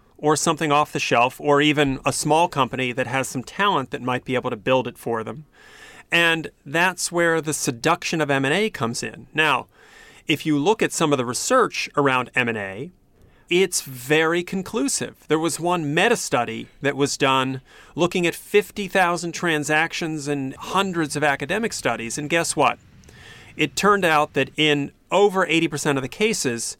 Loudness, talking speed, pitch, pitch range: -21 LUFS, 170 wpm, 150 Hz, 130-170 Hz